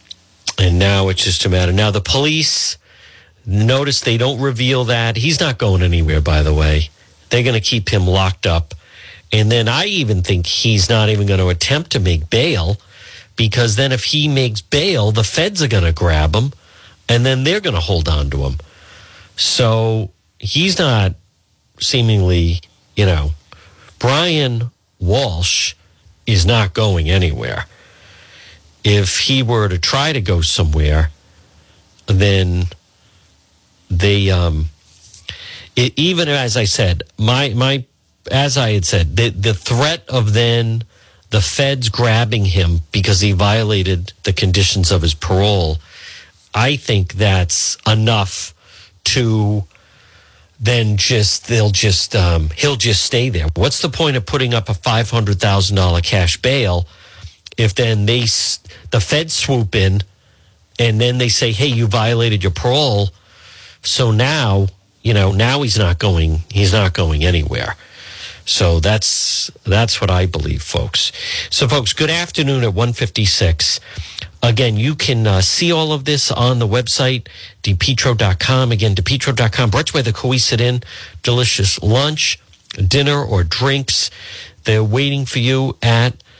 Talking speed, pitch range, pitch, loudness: 145 wpm, 90-120 Hz, 105 Hz, -15 LUFS